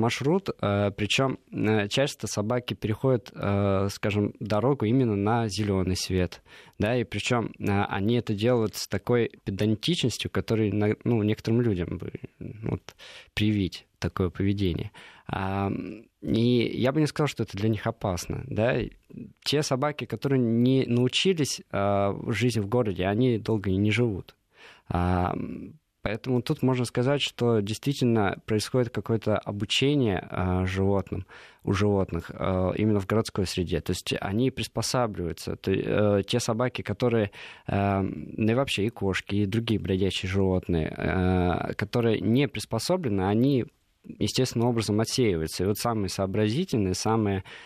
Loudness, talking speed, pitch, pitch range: -27 LUFS, 130 wpm, 110 Hz, 100-120 Hz